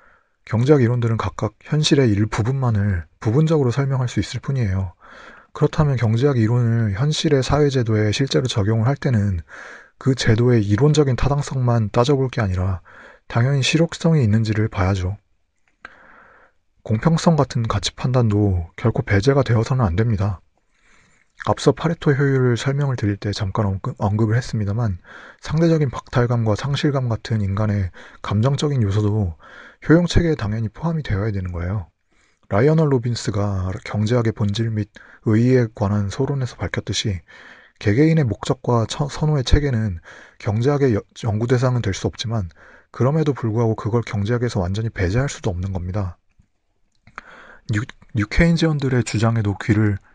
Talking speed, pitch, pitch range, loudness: 335 characters per minute, 115 Hz, 105-135 Hz, -20 LUFS